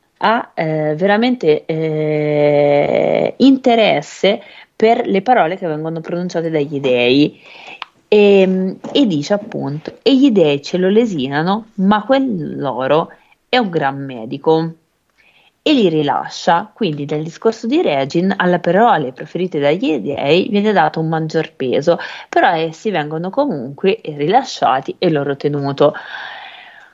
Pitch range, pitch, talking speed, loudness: 150-210 Hz, 165 Hz, 125 wpm, -15 LUFS